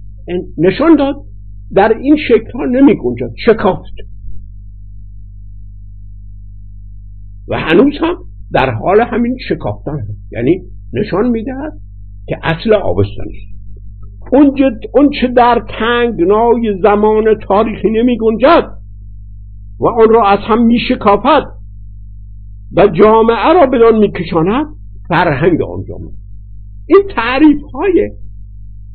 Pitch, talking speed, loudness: 125 Hz, 110 wpm, -11 LUFS